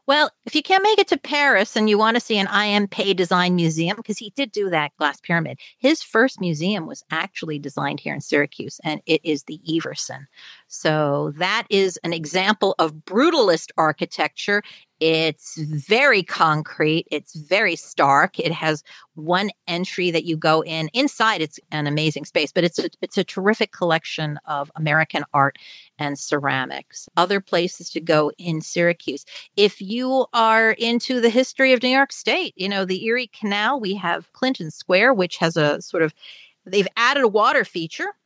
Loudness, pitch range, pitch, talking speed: -20 LUFS, 155-220 Hz, 180 Hz, 175 wpm